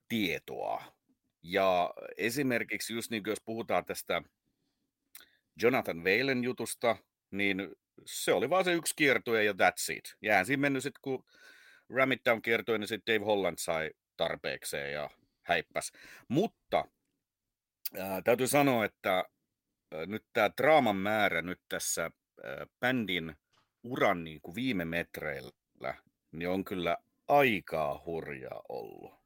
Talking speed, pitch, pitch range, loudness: 130 wpm, 115 Hz, 95-130 Hz, -32 LUFS